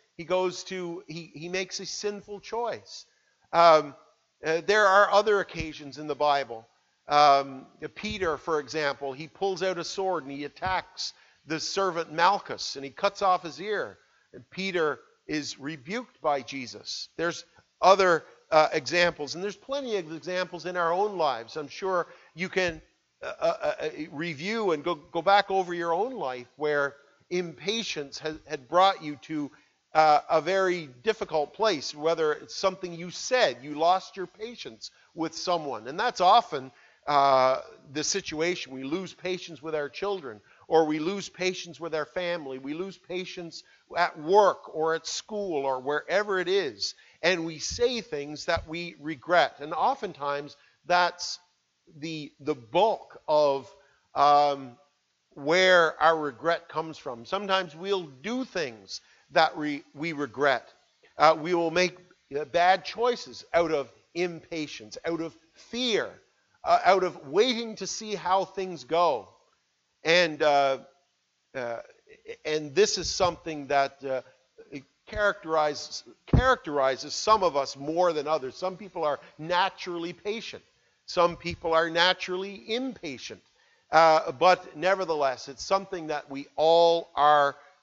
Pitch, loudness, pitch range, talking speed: 170 Hz, -27 LUFS, 150-185 Hz, 145 wpm